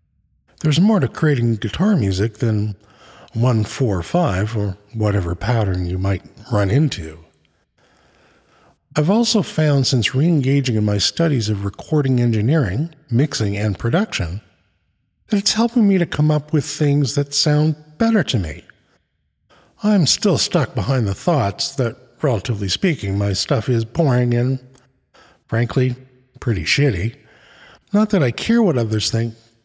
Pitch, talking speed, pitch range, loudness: 125 Hz, 140 wpm, 105-150 Hz, -18 LUFS